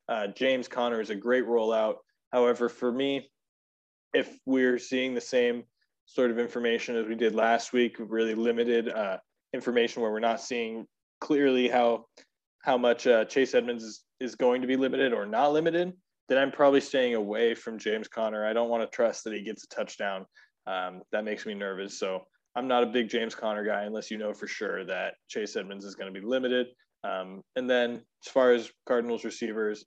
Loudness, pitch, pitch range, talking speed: -29 LUFS, 120 Hz, 110-125 Hz, 195 wpm